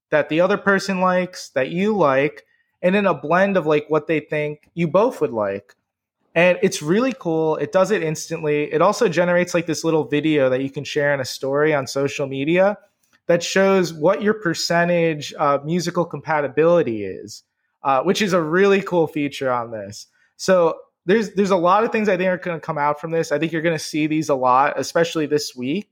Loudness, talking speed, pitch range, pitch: -19 LUFS, 215 wpm, 150-185 Hz, 165 Hz